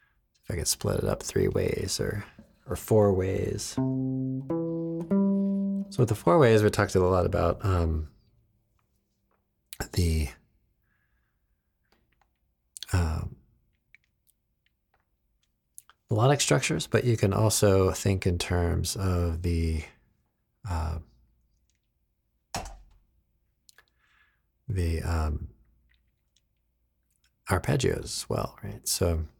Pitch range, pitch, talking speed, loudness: 80-110 Hz, 95 Hz, 90 wpm, -27 LUFS